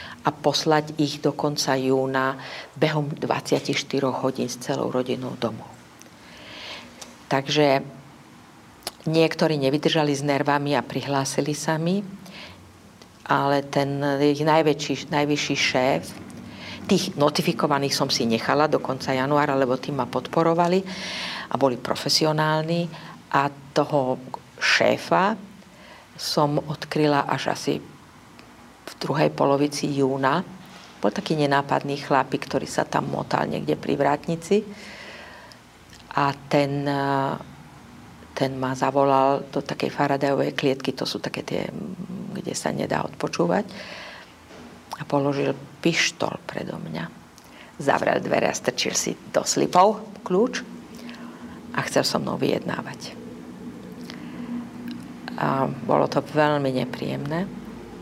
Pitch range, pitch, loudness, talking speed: 135-160 Hz, 145 Hz, -23 LUFS, 110 wpm